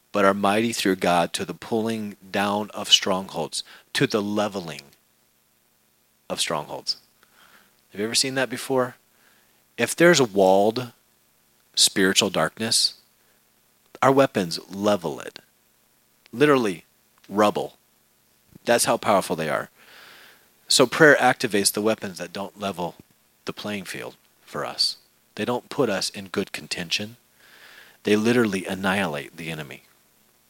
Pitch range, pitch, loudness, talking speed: 95-120 Hz, 105 Hz, -22 LUFS, 125 wpm